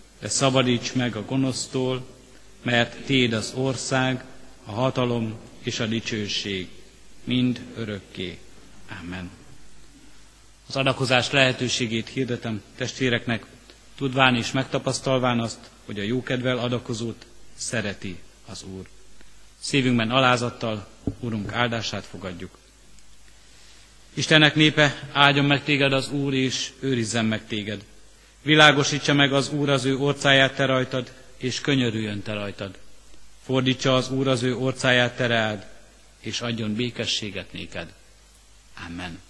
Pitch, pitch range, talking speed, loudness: 120 Hz, 105-130 Hz, 115 wpm, -23 LUFS